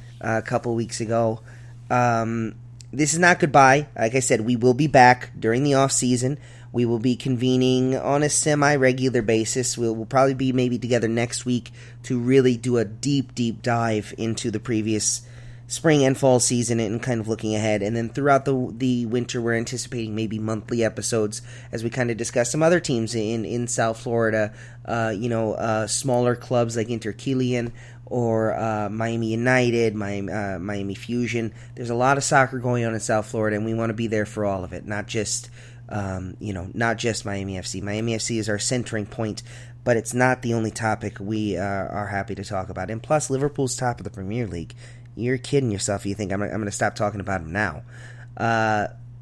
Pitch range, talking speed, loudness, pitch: 110-125 Hz, 205 wpm, -23 LUFS, 120 Hz